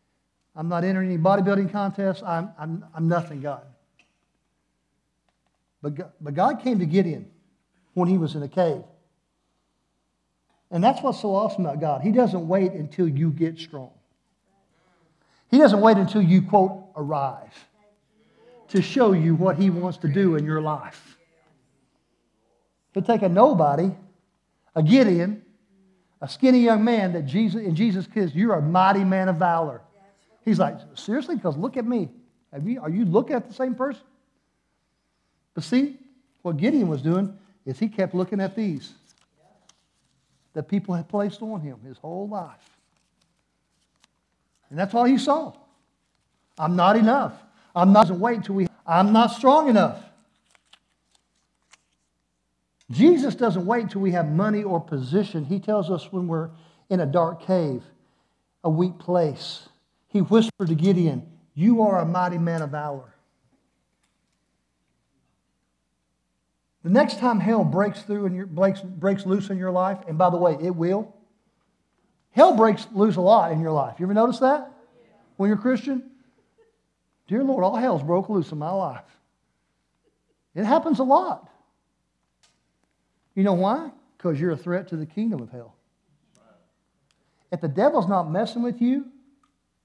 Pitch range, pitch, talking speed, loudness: 165-220 Hz, 190 Hz, 150 wpm, -22 LUFS